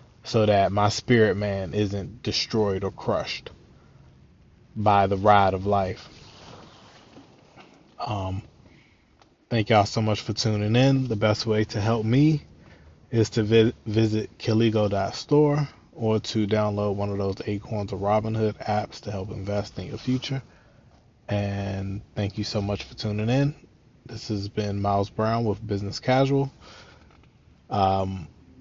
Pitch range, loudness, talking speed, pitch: 100-115 Hz, -25 LUFS, 140 wpm, 105 Hz